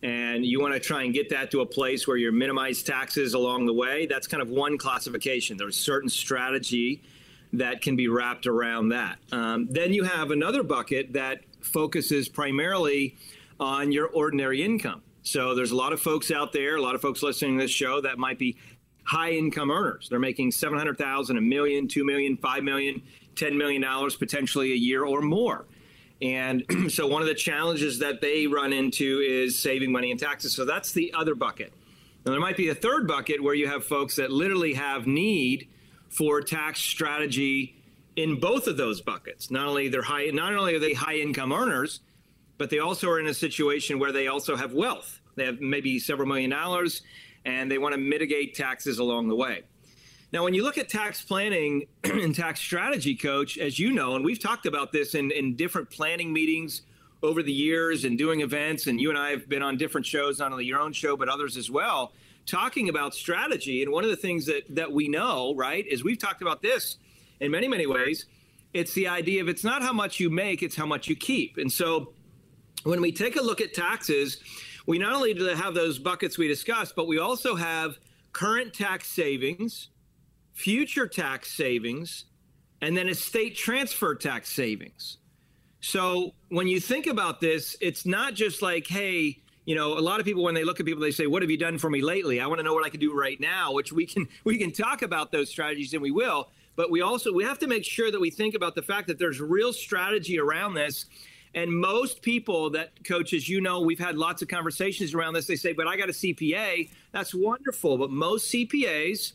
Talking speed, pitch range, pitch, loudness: 210 wpm, 140-175 Hz, 155 Hz, -27 LUFS